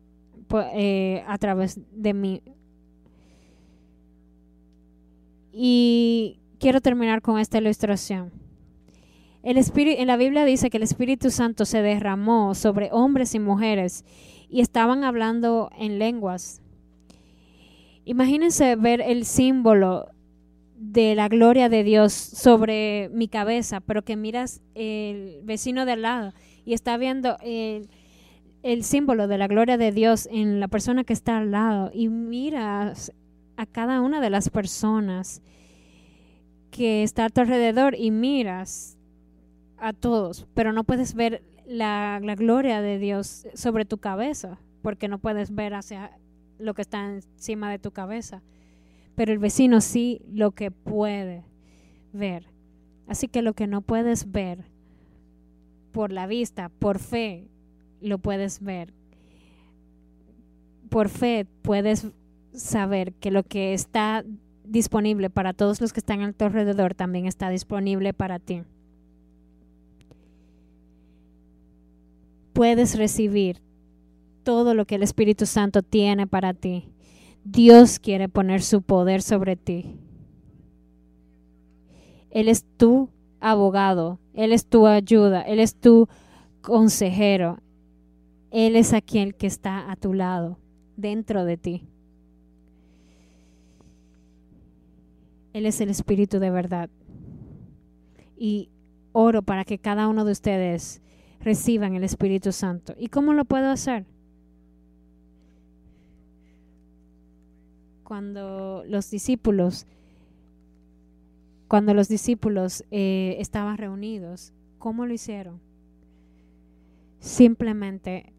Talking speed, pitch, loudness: 120 wpm, 200 Hz, -22 LUFS